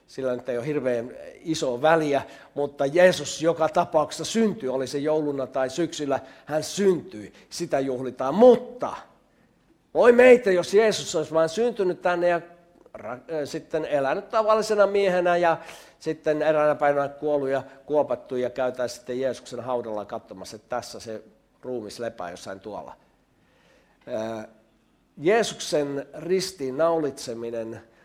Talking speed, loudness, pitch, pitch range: 125 wpm, -24 LUFS, 150 Hz, 130-175 Hz